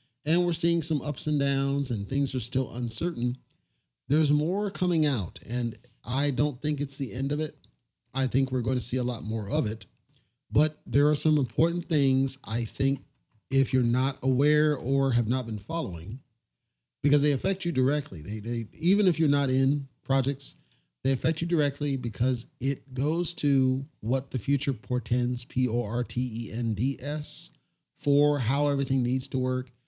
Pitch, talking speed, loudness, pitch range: 135 Hz, 170 wpm, -27 LUFS, 125-145 Hz